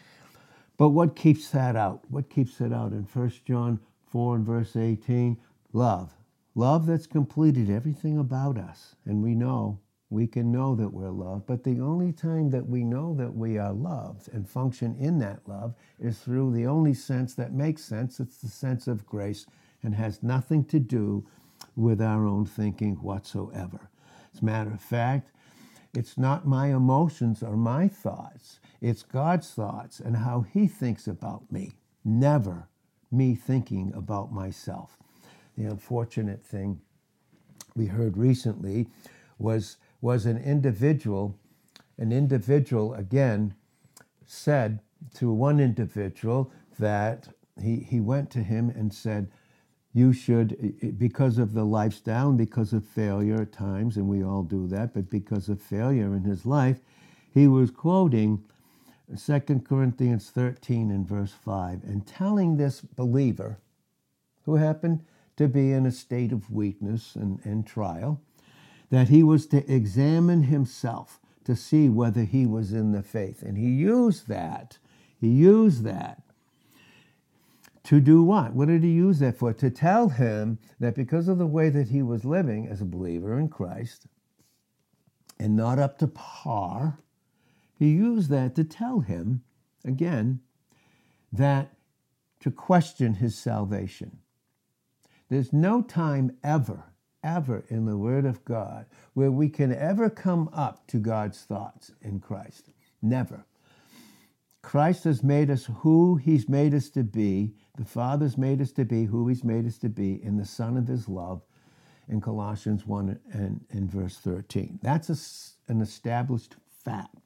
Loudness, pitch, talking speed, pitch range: -26 LUFS, 120 Hz, 150 wpm, 110-140 Hz